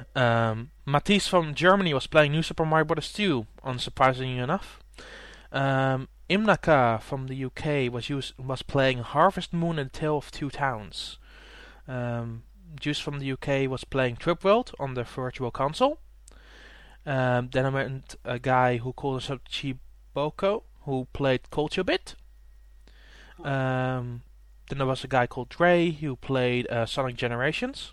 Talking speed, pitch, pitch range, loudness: 150 wpm, 135 Hz, 125-150 Hz, -27 LUFS